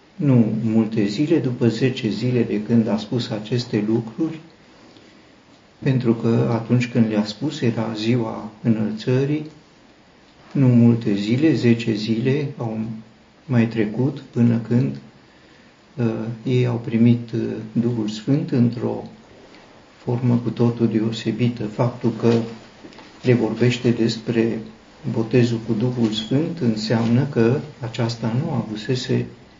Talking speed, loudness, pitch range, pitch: 120 wpm, -21 LUFS, 110-125 Hz, 115 Hz